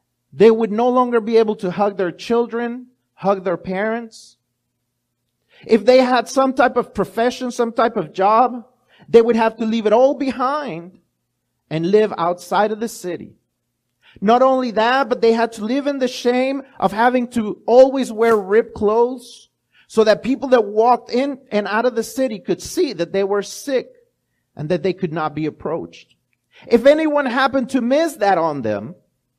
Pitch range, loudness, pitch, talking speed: 190-250 Hz, -18 LUFS, 230 Hz, 180 wpm